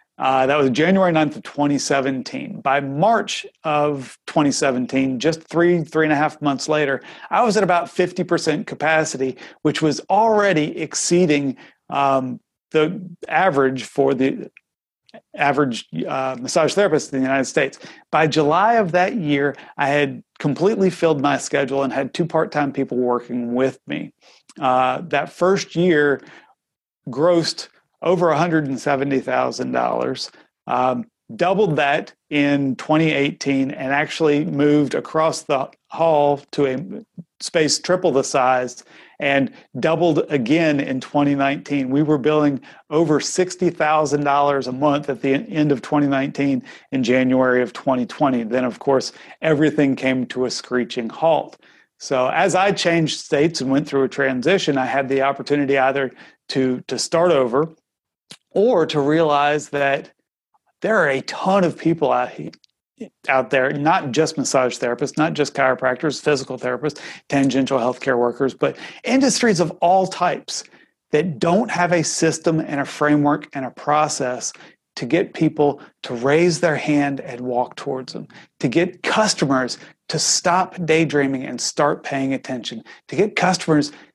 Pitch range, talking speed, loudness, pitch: 135-160 Hz, 145 wpm, -19 LUFS, 145 Hz